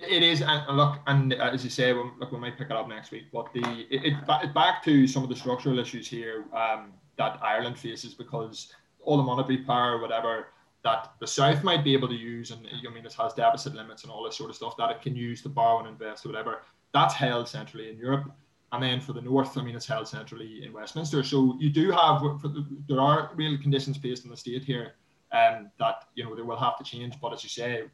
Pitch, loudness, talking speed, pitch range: 125 Hz, -27 LUFS, 250 wpm, 115-140 Hz